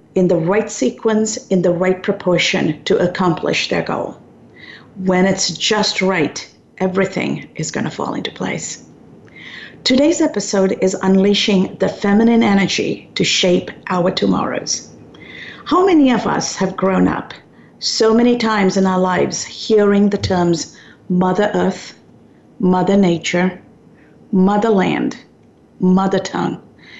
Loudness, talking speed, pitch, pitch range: -16 LUFS, 125 wpm, 190 Hz, 185-215 Hz